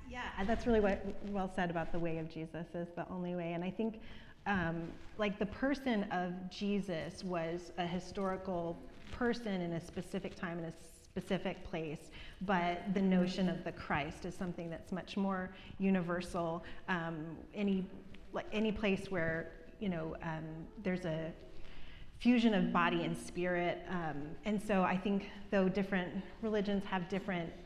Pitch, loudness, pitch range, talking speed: 185 Hz, -38 LUFS, 170-200 Hz, 160 wpm